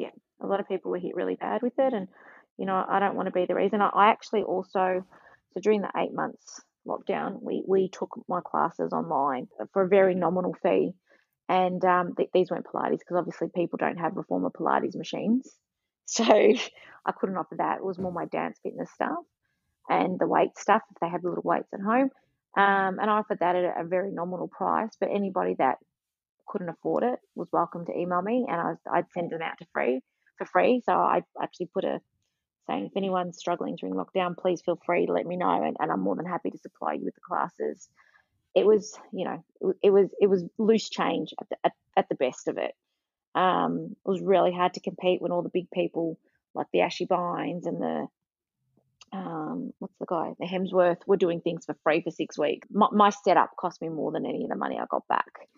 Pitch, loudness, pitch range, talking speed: 185 Hz, -27 LUFS, 175-205 Hz, 225 wpm